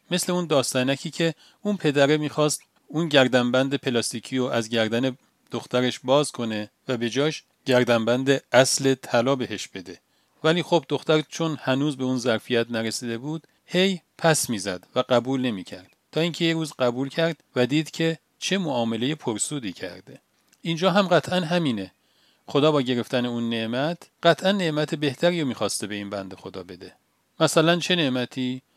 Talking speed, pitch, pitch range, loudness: 155 wpm, 140 Hz, 120-165 Hz, -24 LUFS